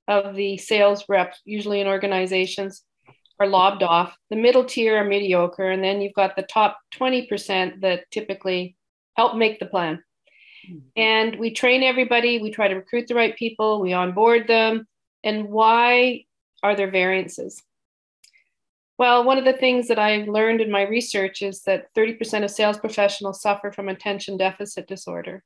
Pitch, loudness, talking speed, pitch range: 205 Hz, -21 LUFS, 165 wpm, 190-225 Hz